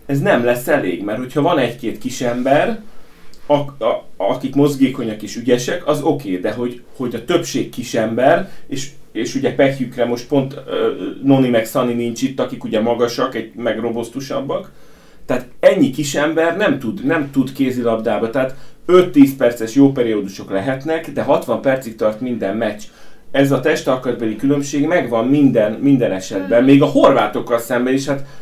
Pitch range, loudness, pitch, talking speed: 120-145 Hz, -17 LUFS, 130 Hz, 165 wpm